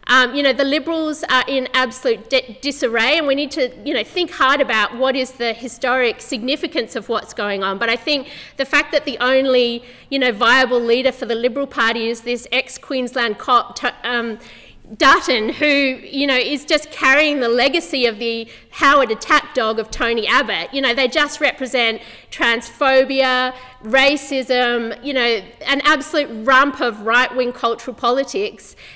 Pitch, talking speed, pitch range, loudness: 255 Hz, 170 wpm, 235-280 Hz, -17 LUFS